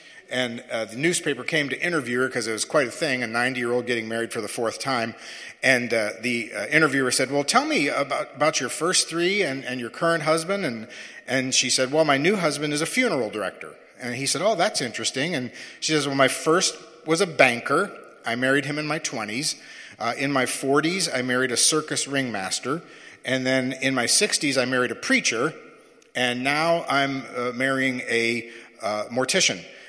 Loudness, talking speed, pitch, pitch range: -23 LUFS, 205 wpm, 135 Hz, 125-155 Hz